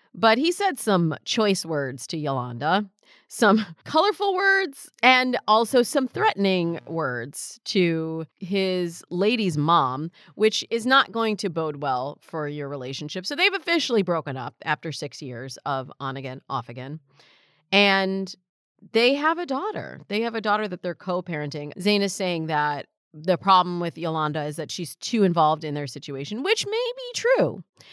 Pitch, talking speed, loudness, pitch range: 185 Hz, 165 wpm, -24 LUFS, 150-225 Hz